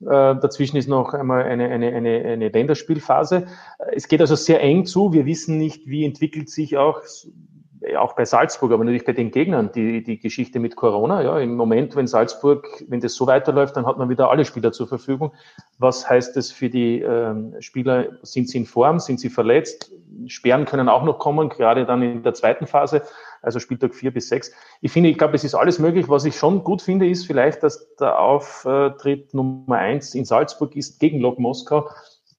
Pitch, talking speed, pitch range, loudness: 140 Hz, 200 wpm, 125-155 Hz, -19 LUFS